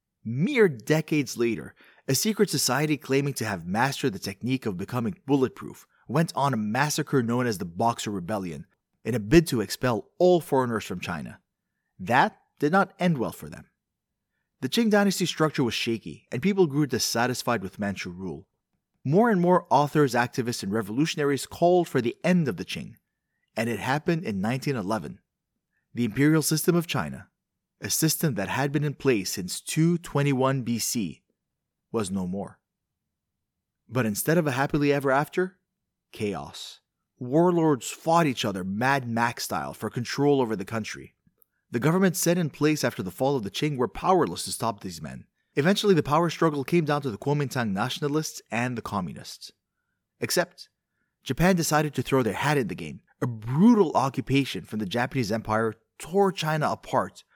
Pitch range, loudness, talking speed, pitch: 115-160 Hz, -26 LUFS, 165 wpm, 135 Hz